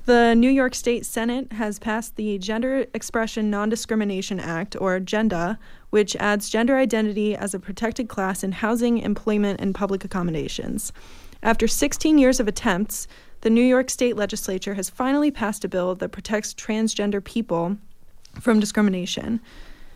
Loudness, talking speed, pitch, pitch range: -23 LUFS, 150 wpm, 215 Hz, 200-235 Hz